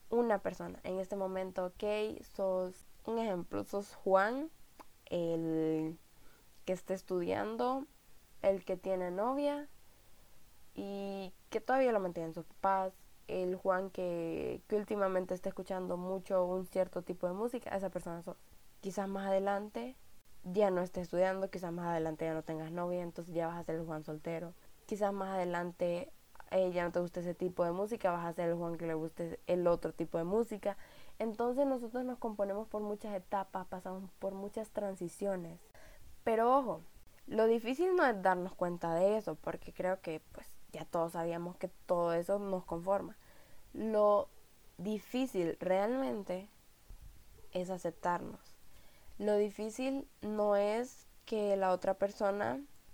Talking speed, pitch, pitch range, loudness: 155 wpm, 190 Hz, 175-210 Hz, -36 LUFS